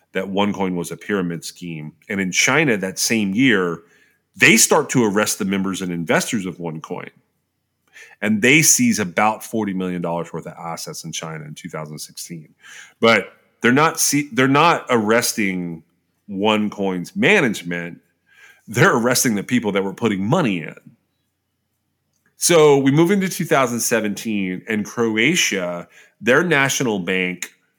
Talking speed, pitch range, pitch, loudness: 135 wpm, 85-115 Hz, 95 Hz, -18 LUFS